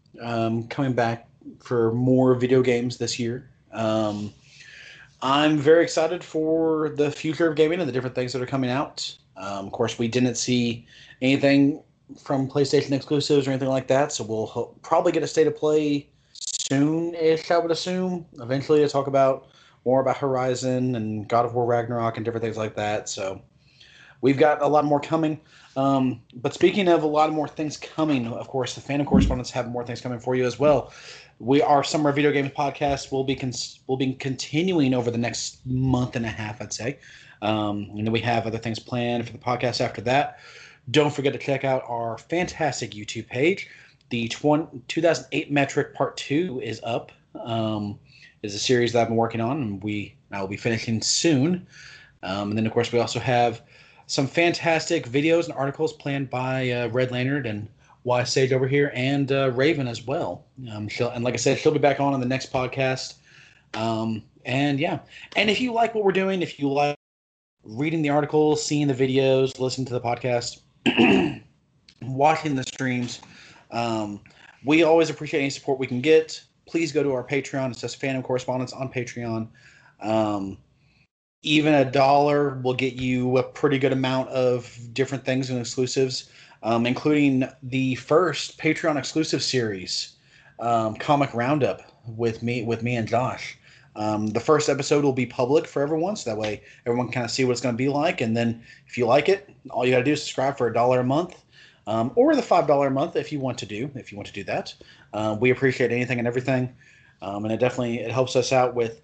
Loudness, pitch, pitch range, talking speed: -24 LUFS, 130 Hz, 120-145 Hz, 195 wpm